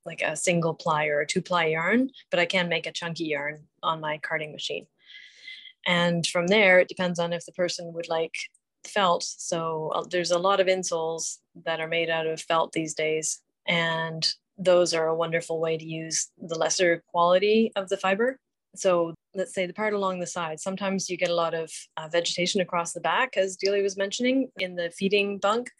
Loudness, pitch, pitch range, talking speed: -26 LUFS, 175 Hz, 165-190 Hz, 205 wpm